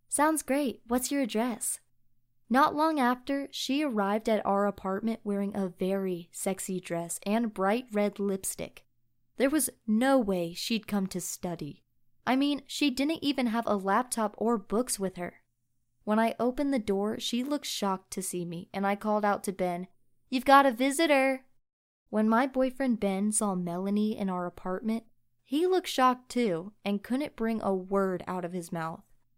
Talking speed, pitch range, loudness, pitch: 175 wpm, 185-255 Hz, -29 LUFS, 210 Hz